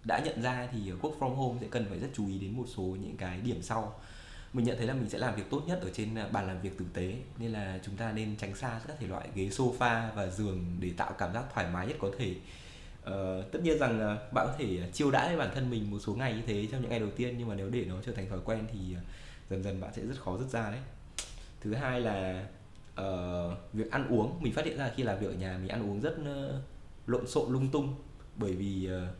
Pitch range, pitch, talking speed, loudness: 95-125 Hz, 110 Hz, 270 wpm, -35 LUFS